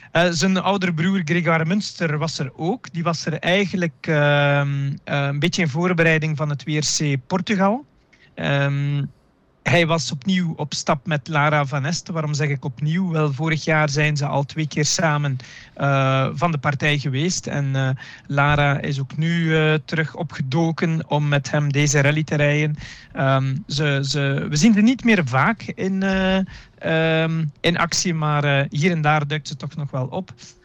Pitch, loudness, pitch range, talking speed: 155 Hz, -20 LUFS, 145-170 Hz, 180 wpm